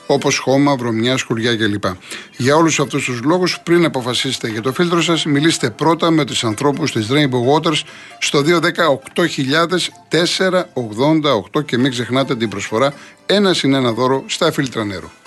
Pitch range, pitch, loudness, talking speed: 125-160 Hz, 140 Hz, -16 LUFS, 145 wpm